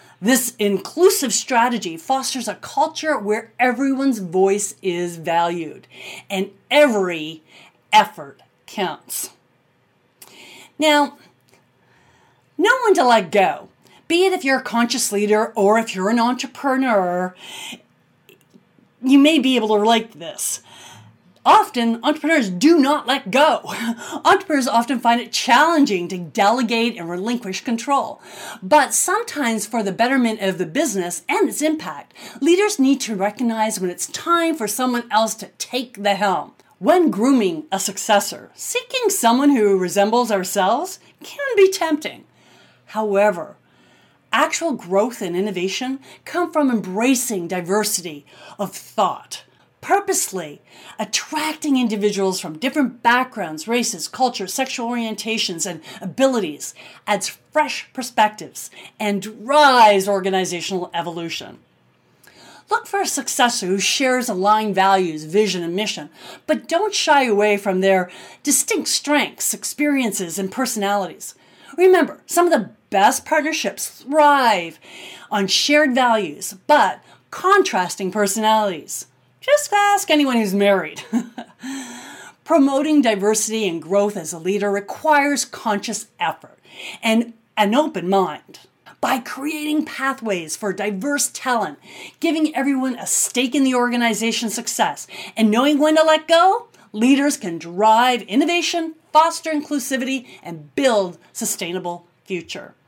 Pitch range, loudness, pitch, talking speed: 200-290 Hz, -19 LUFS, 235 Hz, 120 wpm